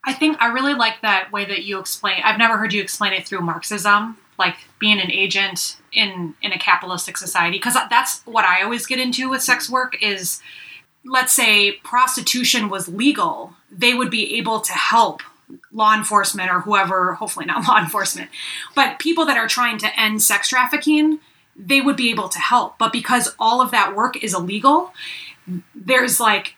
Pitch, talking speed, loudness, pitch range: 220 Hz, 185 wpm, -17 LUFS, 195-255 Hz